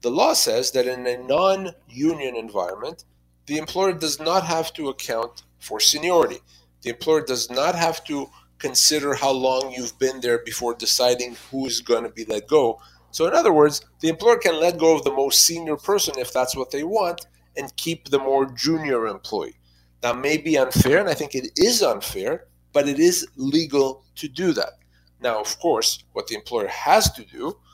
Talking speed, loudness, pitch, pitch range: 195 wpm, -21 LUFS, 135 Hz, 120-160 Hz